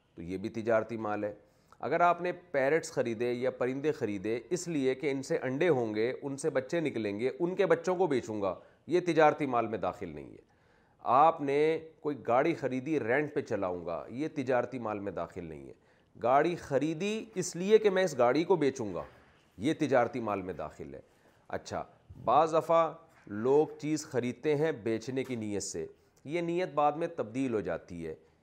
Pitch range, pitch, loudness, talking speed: 110-160 Hz, 135 Hz, -31 LUFS, 195 wpm